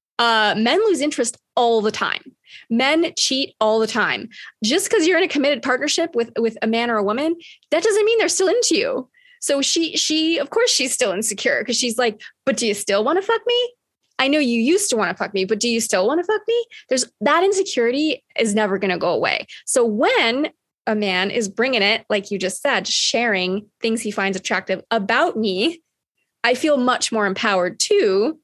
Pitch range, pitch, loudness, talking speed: 215-335 Hz, 245 Hz, -19 LUFS, 215 wpm